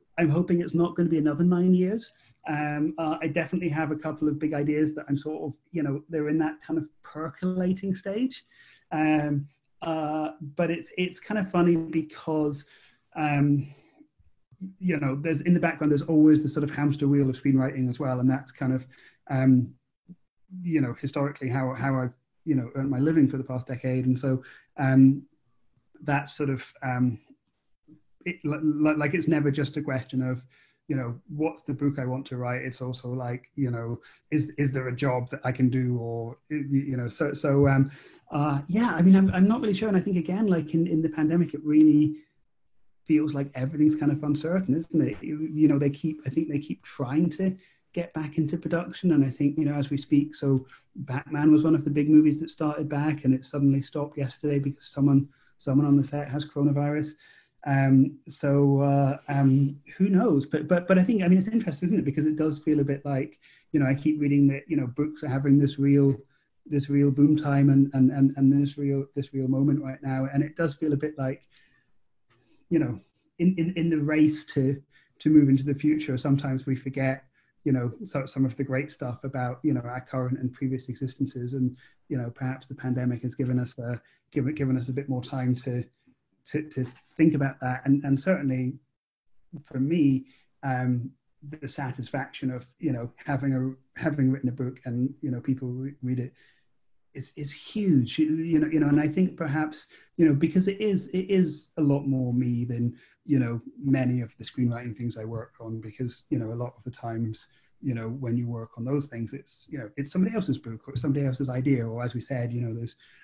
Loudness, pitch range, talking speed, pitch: -26 LUFS, 130-155 Hz, 215 wpm, 140 Hz